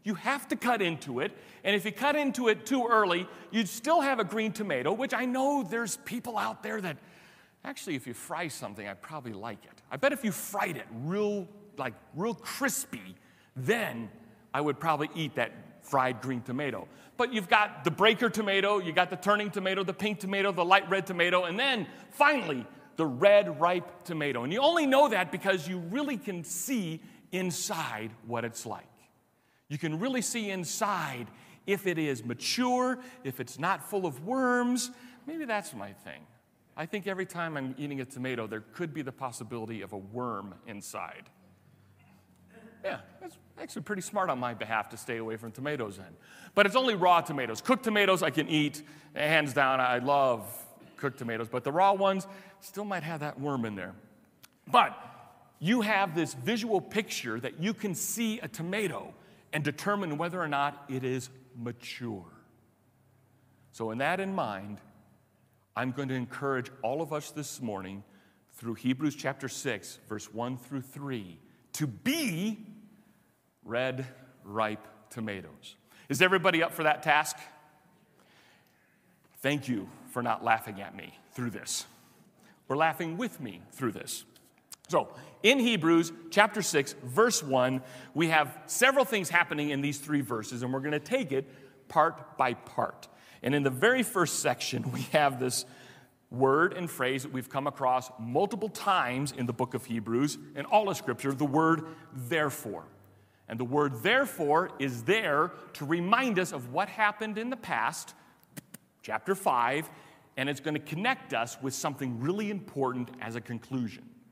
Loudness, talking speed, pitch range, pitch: -30 LUFS, 170 wpm, 125-200 Hz, 150 Hz